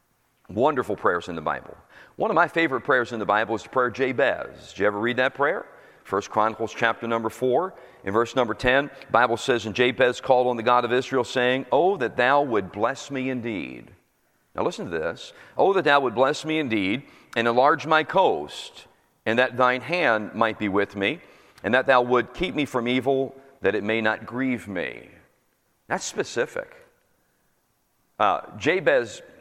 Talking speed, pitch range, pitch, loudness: 190 wpm, 115-135 Hz, 125 Hz, -23 LUFS